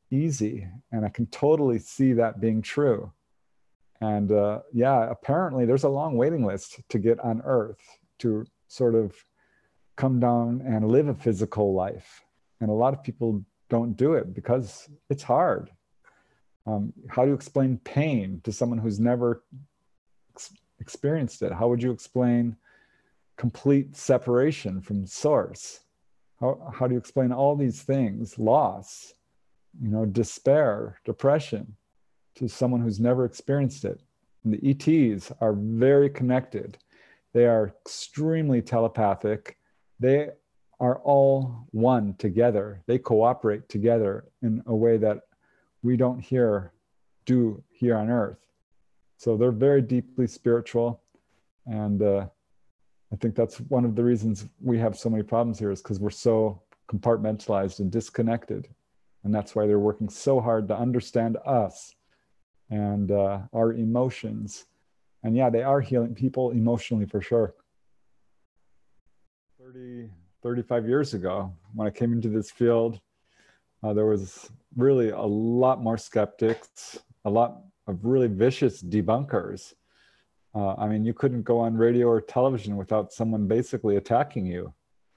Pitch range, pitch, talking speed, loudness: 105-125 Hz, 115 Hz, 140 wpm, -25 LUFS